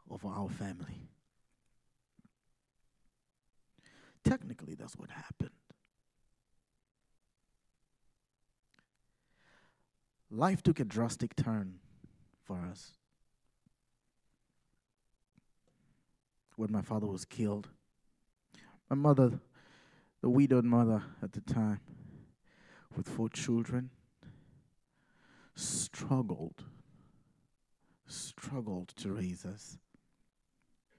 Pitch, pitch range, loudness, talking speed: 115 Hz, 100-130 Hz, -35 LUFS, 70 wpm